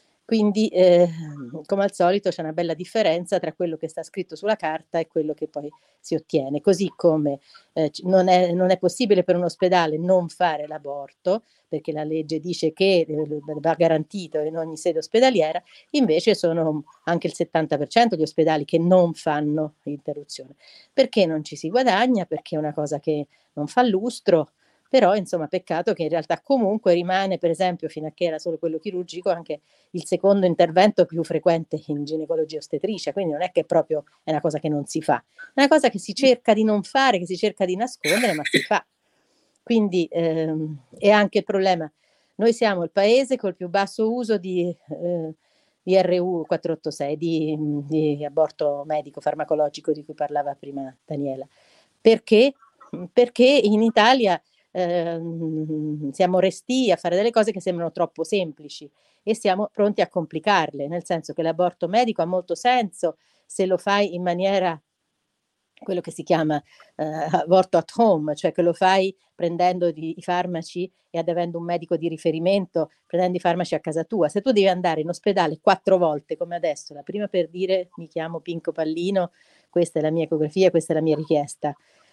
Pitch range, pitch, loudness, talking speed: 155-190 Hz, 175 Hz, -22 LUFS, 175 wpm